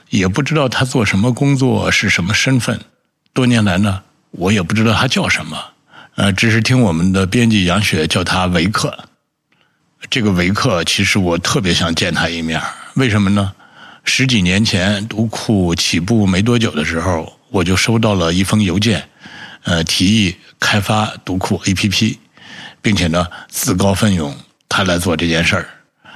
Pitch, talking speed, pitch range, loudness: 100 Hz, 250 characters per minute, 90-115 Hz, -15 LUFS